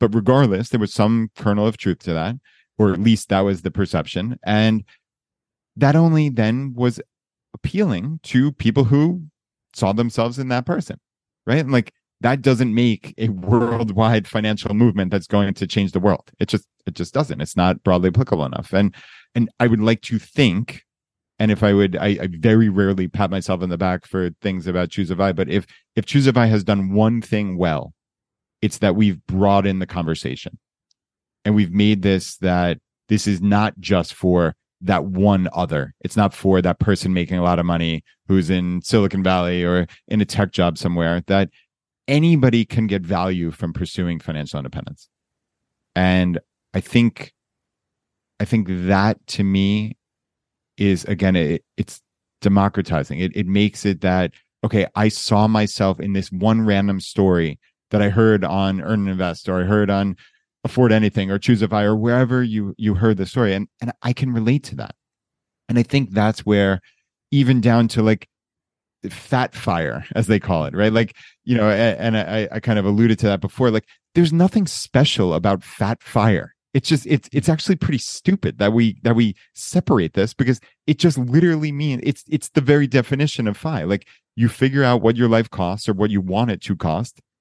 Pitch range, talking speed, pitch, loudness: 95-120 Hz, 190 wpm, 105 Hz, -19 LUFS